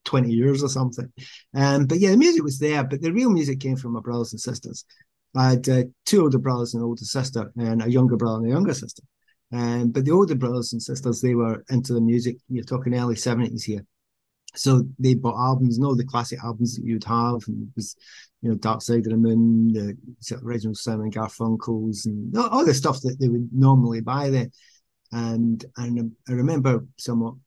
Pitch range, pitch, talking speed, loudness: 115-130 Hz, 120 Hz, 210 wpm, -22 LUFS